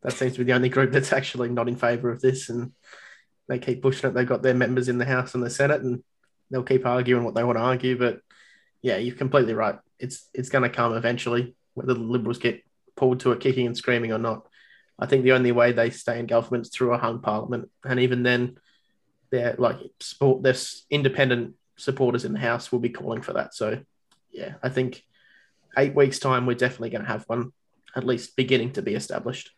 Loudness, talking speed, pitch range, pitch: -24 LUFS, 225 wpm, 120-130 Hz, 125 Hz